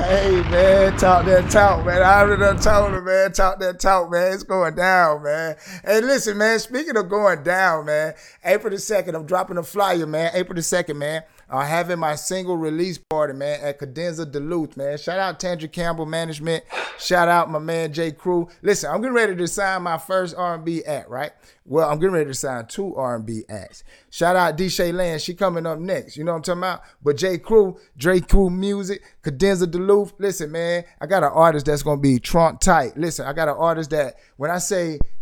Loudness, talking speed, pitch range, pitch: -20 LUFS, 215 wpm, 160-190 Hz, 175 Hz